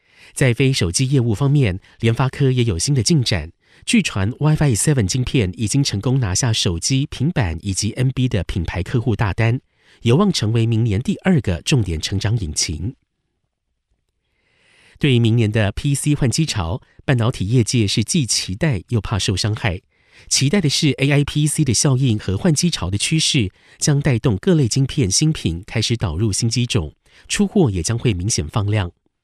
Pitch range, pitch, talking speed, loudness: 105-140 Hz, 120 Hz, 275 characters per minute, -18 LUFS